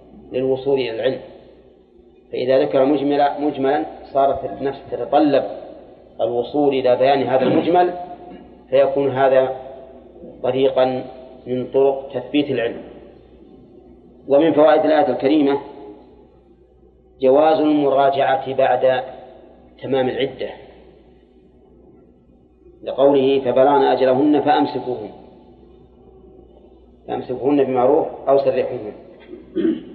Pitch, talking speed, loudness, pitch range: 135 Hz, 75 wpm, -18 LUFS, 130-145 Hz